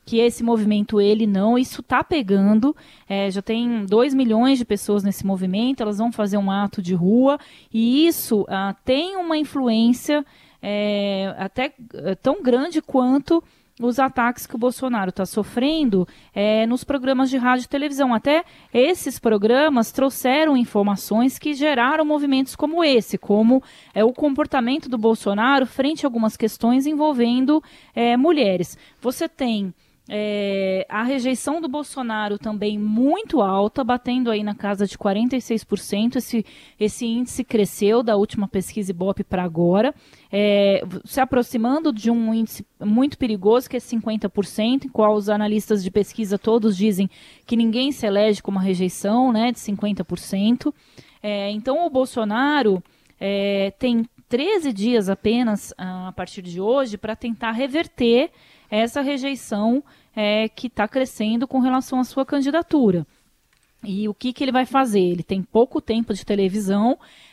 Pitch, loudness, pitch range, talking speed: 230 Hz, -21 LUFS, 205-265 Hz, 150 wpm